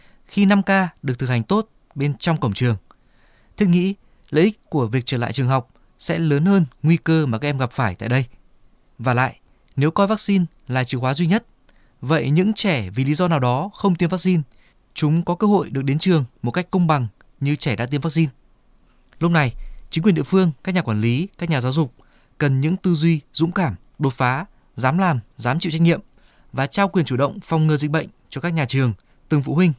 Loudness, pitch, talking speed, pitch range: -20 LUFS, 150 Hz, 230 wpm, 130-175 Hz